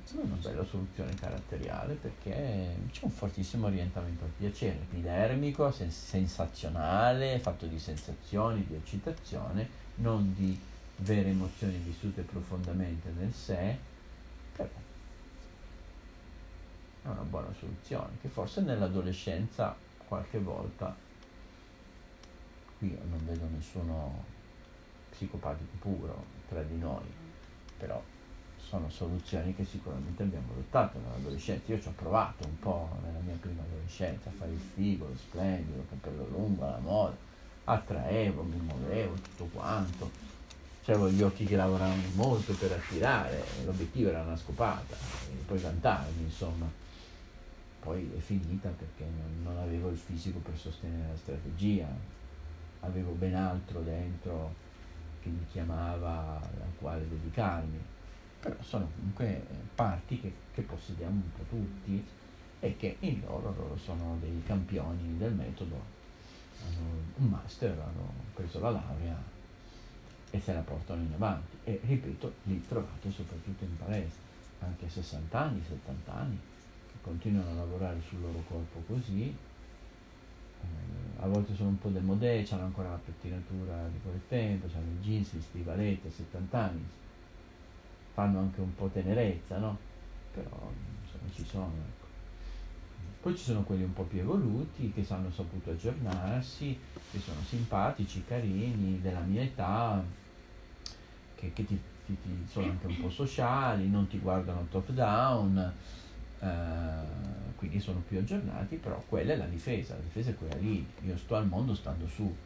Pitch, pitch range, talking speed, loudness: 90 Hz, 85-100 Hz, 135 wpm, -36 LUFS